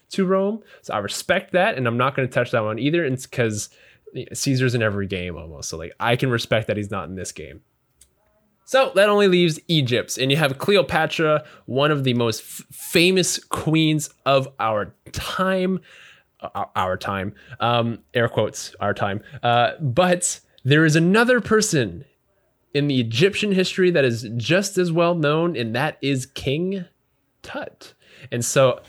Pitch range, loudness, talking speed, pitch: 120-180 Hz, -21 LUFS, 170 wpm, 140 Hz